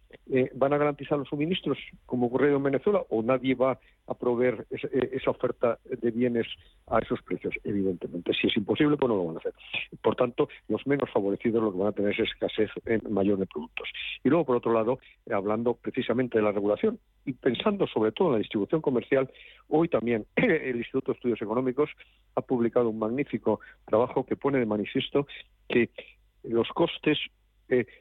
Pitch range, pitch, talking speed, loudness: 110-140 Hz, 125 Hz, 185 wpm, -28 LUFS